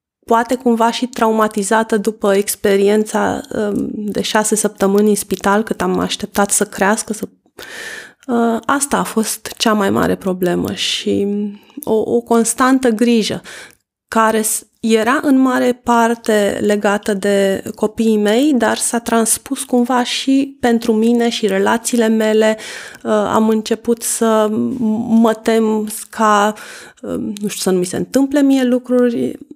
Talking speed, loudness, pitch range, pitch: 130 wpm, -15 LUFS, 210-240 Hz, 225 Hz